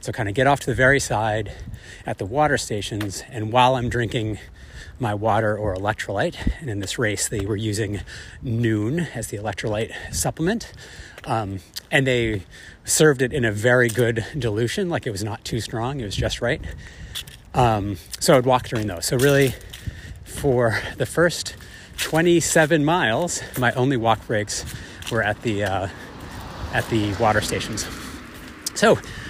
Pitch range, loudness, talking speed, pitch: 105-130 Hz, -22 LUFS, 160 wpm, 110 Hz